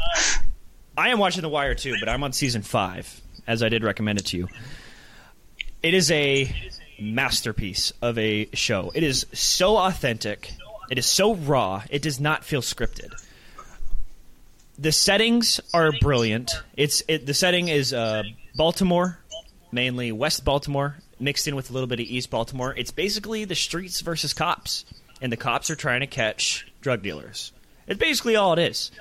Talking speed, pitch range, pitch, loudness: 170 wpm, 115-160 Hz, 135 Hz, -23 LUFS